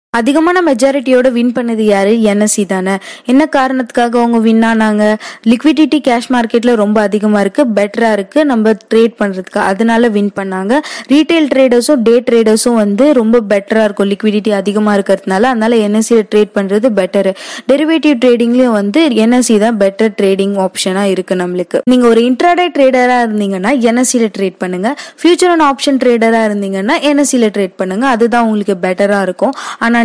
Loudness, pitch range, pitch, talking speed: -11 LUFS, 205-255 Hz, 230 Hz, 145 wpm